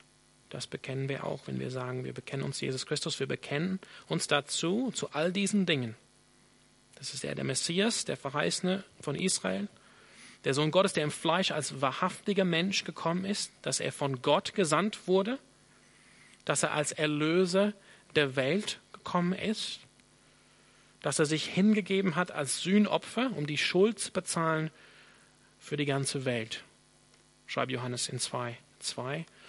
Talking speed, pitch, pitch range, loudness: 150 wpm, 165 Hz, 140-195 Hz, -31 LUFS